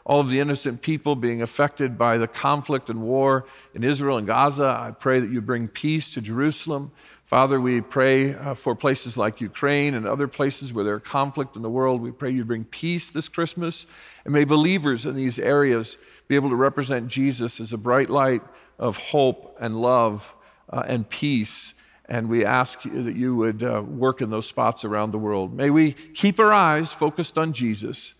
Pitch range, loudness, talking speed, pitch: 120-145 Hz, -23 LUFS, 190 wpm, 130 Hz